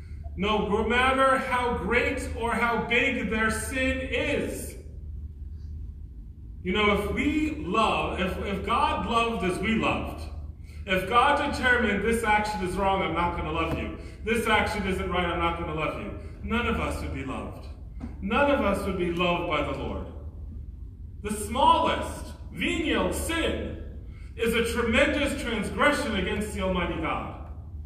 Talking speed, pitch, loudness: 155 wpm, 195 Hz, -26 LUFS